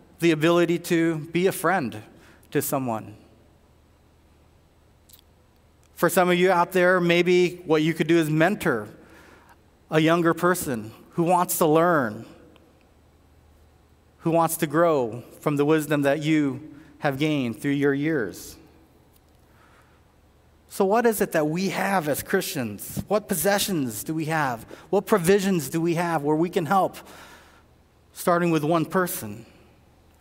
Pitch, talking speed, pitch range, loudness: 160 Hz, 135 wpm, 110-175 Hz, -23 LUFS